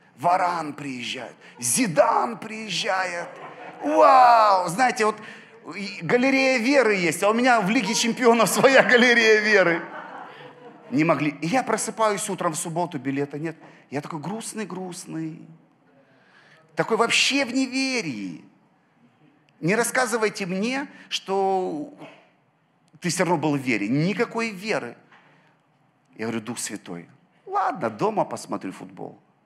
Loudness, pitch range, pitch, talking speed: -22 LUFS, 160-235 Hz, 200 Hz, 115 wpm